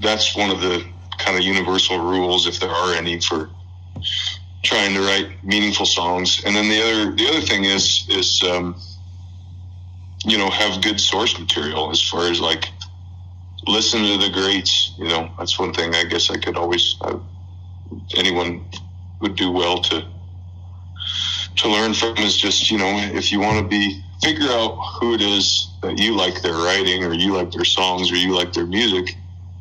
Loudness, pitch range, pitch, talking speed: -18 LUFS, 90-100 Hz, 90 Hz, 180 wpm